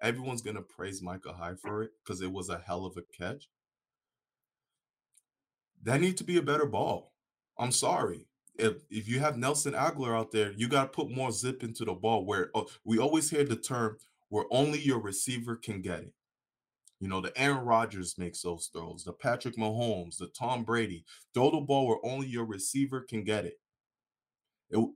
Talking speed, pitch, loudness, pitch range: 190 wpm, 115 Hz, -32 LUFS, 95-130 Hz